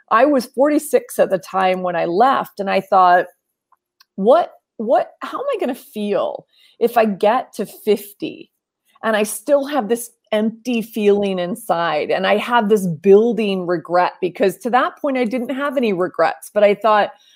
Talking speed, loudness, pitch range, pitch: 175 wpm, -18 LUFS, 195-270 Hz, 220 Hz